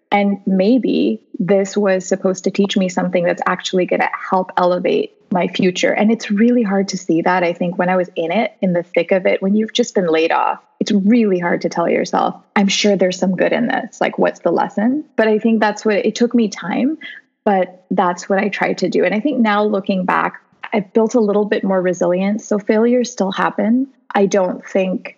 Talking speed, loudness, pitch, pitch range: 225 wpm, -17 LUFS, 200 Hz, 185-225 Hz